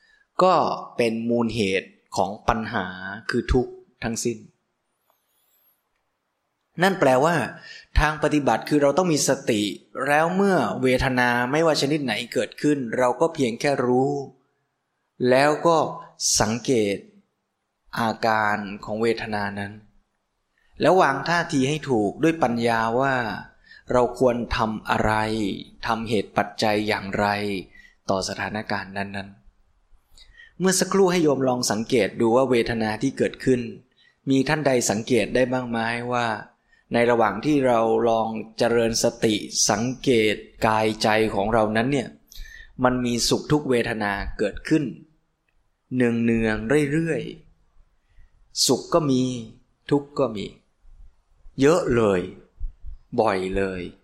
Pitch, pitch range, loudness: 120 Hz, 105-140 Hz, -22 LUFS